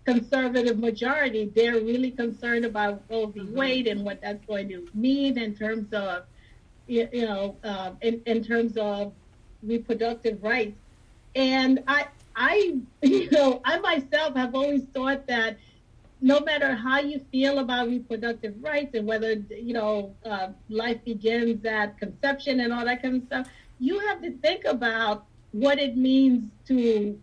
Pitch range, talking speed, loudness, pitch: 215-270 Hz, 150 wpm, -26 LUFS, 235 Hz